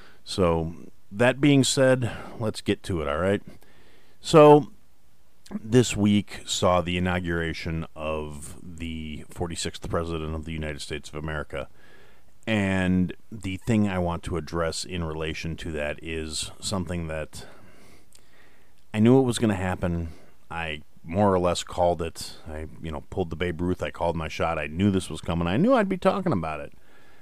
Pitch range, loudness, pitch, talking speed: 80-100 Hz, -25 LUFS, 85 Hz, 170 wpm